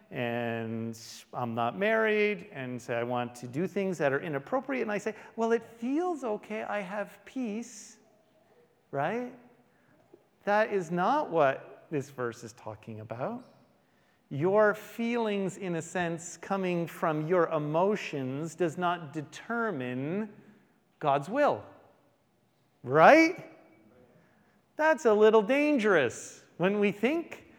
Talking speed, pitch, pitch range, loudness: 125 wpm, 195 Hz, 140-220 Hz, -29 LUFS